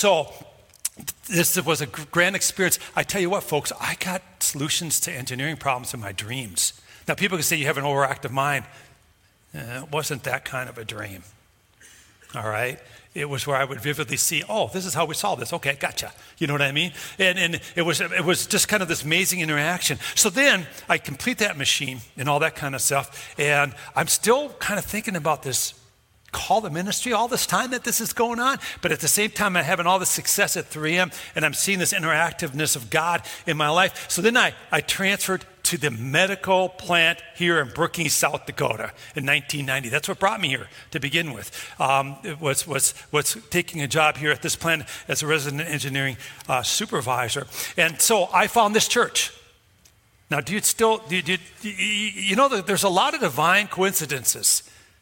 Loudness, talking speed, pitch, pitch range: -22 LUFS, 205 wpm, 155 Hz, 135-185 Hz